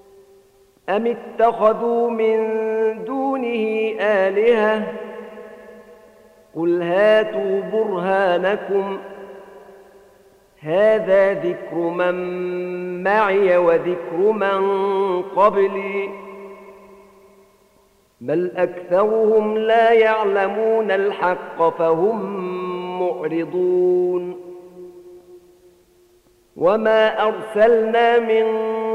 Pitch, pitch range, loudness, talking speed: 200 Hz, 180-220 Hz, -19 LUFS, 55 wpm